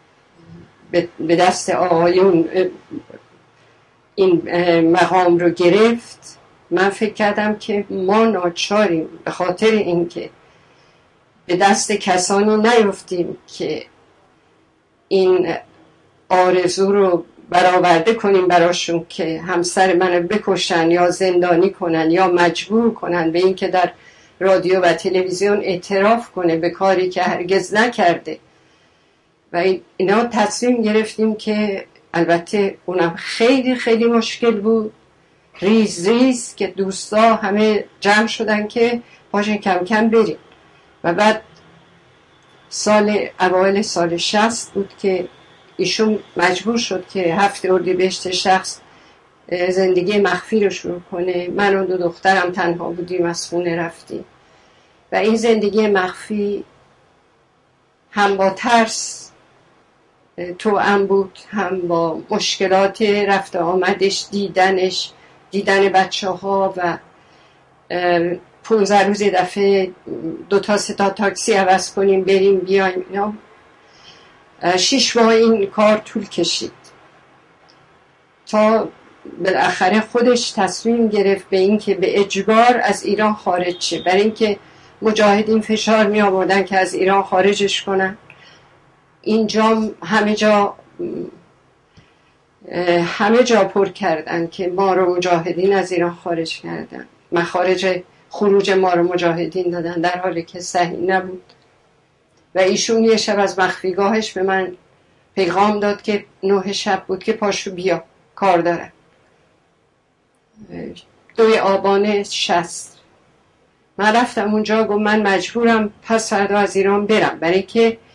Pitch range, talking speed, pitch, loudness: 180-210 Hz, 115 wpm, 195 Hz, -17 LUFS